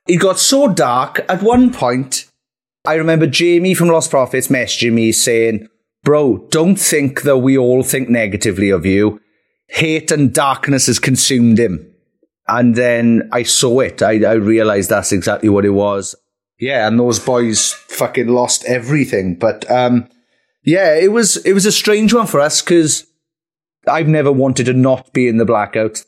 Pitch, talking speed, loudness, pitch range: 125 Hz, 170 wpm, -13 LUFS, 115-160 Hz